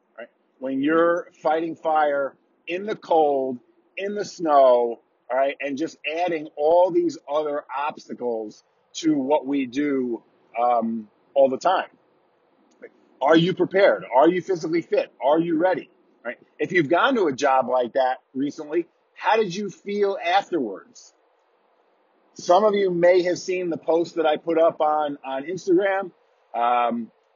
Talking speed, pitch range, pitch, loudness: 150 wpm, 140-195 Hz, 160 Hz, -22 LUFS